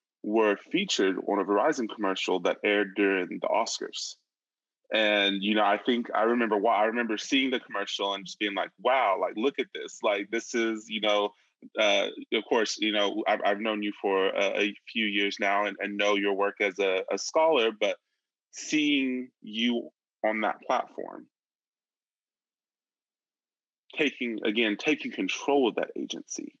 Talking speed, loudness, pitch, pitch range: 170 wpm, -27 LUFS, 110 Hz, 100-130 Hz